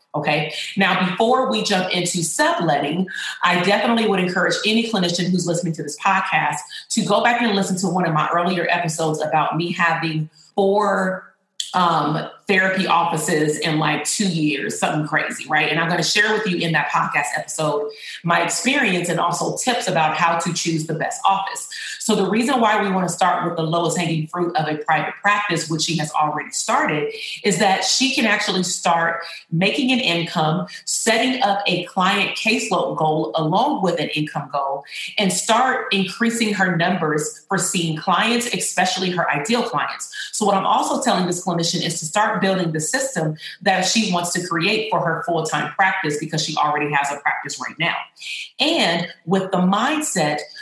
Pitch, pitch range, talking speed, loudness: 175 Hz, 160-200 Hz, 185 wpm, -19 LUFS